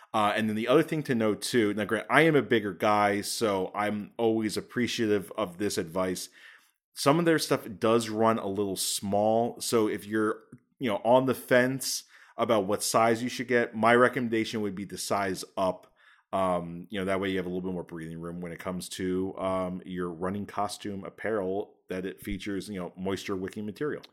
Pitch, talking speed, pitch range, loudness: 105 Hz, 205 wpm, 95-115 Hz, -28 LUFS